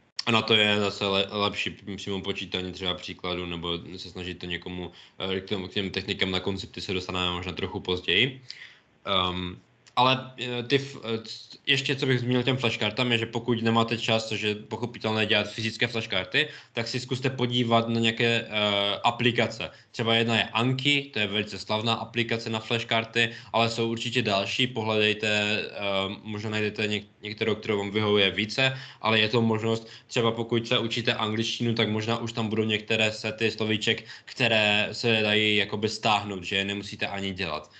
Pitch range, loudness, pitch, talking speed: 100-115 Hz, -26 LUFS, 110 Hz, 165 wpm